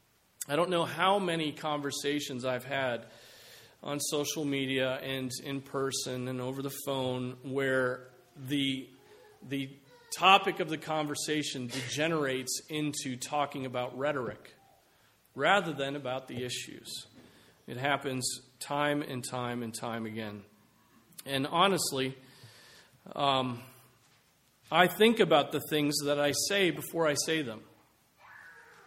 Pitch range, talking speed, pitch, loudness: 130-150 Hz, 120 wpm, 140 Hz, -31 LUFS